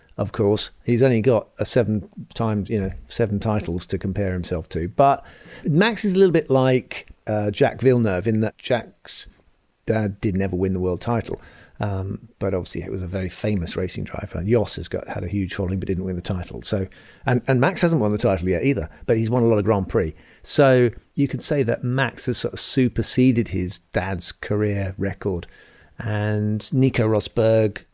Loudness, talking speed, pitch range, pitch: -22 LUFS, 200 wpm, 95-125 Hz, 105 Hz